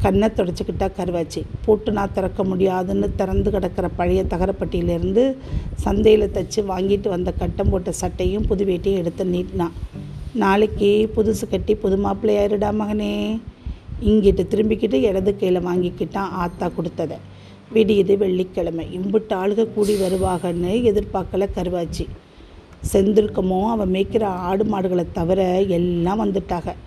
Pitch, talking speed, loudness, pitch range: 195 Hz, 110 wpm, -20 LUFS, 180-210 Hz